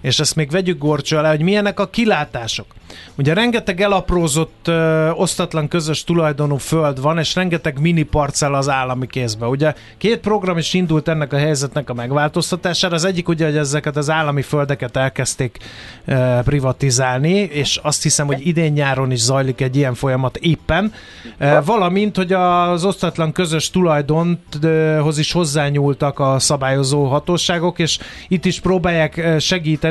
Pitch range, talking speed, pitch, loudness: 140-175 Hz, 150 wpm, 155 Hz, -17 LUFS